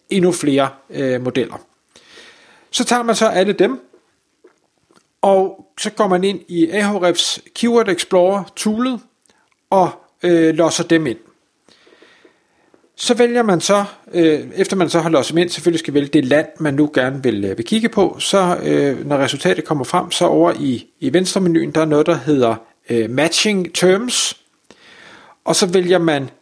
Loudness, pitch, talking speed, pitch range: -16 LUFS, 175 Hz, 170 wpm, 150-205 Hz